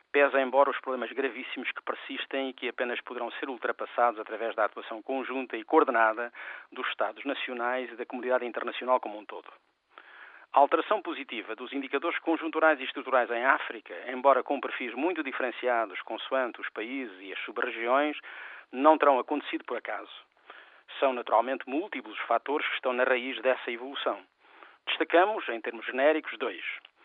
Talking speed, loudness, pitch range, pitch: 160 wpm, -29 LUFS, 125-140 Hz, 130 Hz